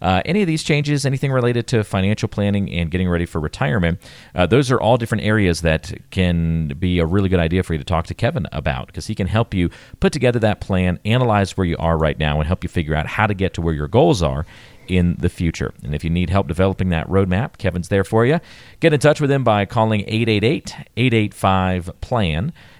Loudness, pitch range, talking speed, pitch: -19 LUFS, 85-115 Hz, 230 wpm, 95 Hz